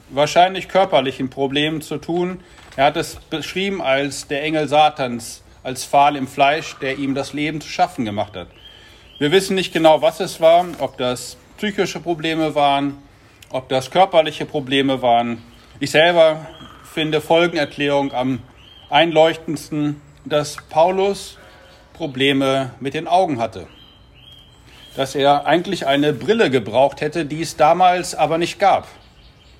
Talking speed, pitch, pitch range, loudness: 140 wpm, 150 Hz, 135-165 Hz, -18 LUFS